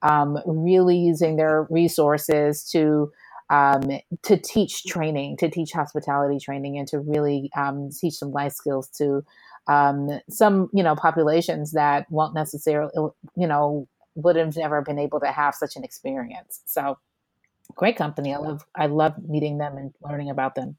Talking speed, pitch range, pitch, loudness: 160 wpm, 145-165 Hz, 150 Hz, -23 LUFS